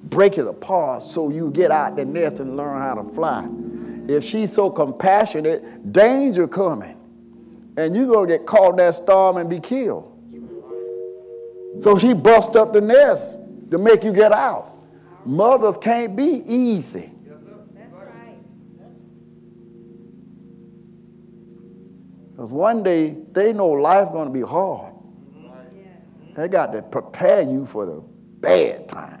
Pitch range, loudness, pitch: 150-220 Hz, -18 LUFS, 195 Hz